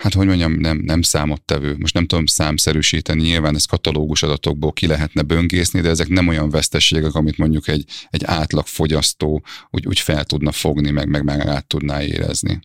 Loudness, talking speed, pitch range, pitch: -17 LUFS, 180 wpm, 75-85 Hz, 80 Hz